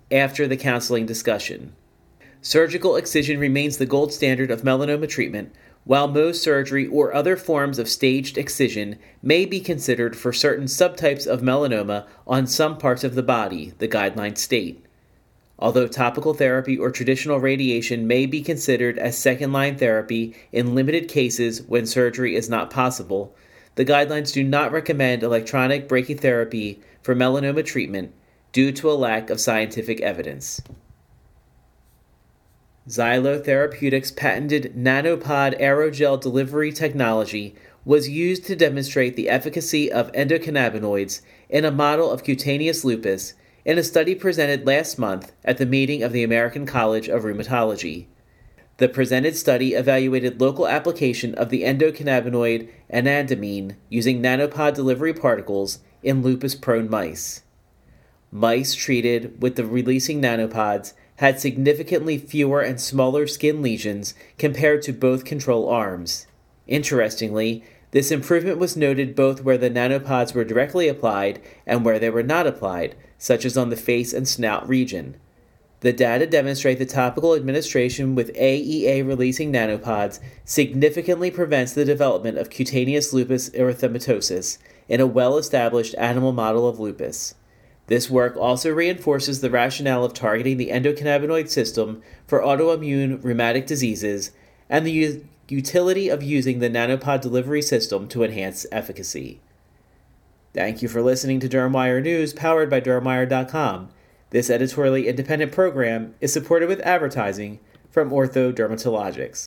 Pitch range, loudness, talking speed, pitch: 120-145 Hz, -21 LUFS, 135 wpm, 130 Hz